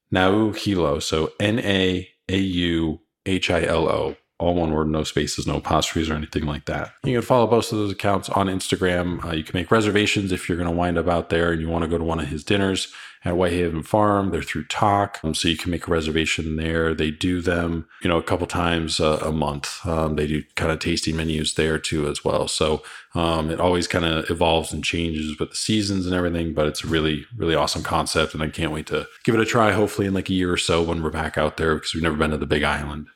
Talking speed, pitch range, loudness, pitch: 250 wpm, 80-95 Hz, -22 LUFS, 85 Hz